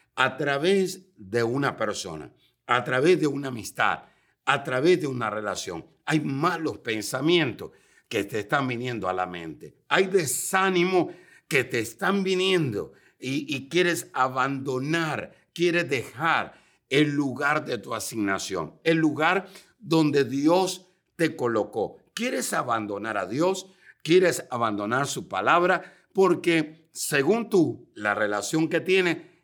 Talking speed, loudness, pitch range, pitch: 130 wpm, -25 LUFS, 125-175 Hz, 155 Hz